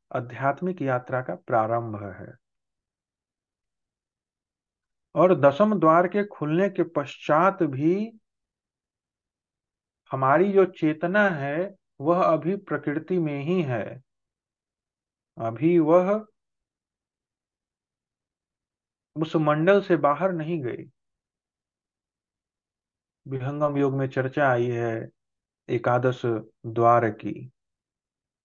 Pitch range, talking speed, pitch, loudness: 125-180 Hz, 85 wpm, 150 Hz, -24 LUFS